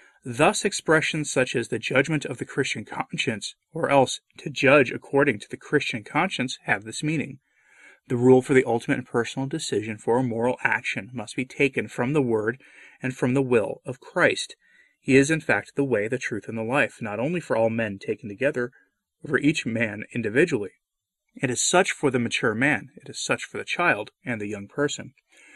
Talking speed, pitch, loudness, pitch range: 200 wpm, 135 Hz, -24 LUFS, 120-150 Hz